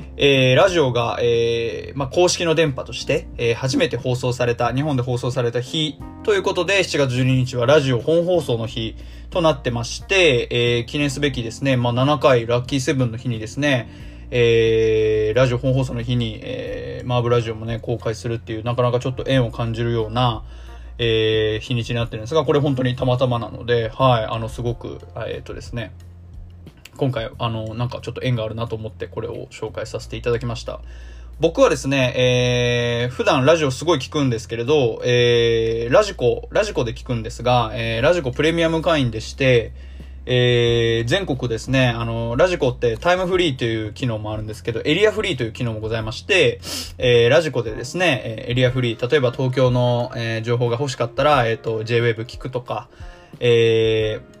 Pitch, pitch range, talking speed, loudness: 120 Hz, 115-130 Hz, 385 characters per minute, -20 LUFS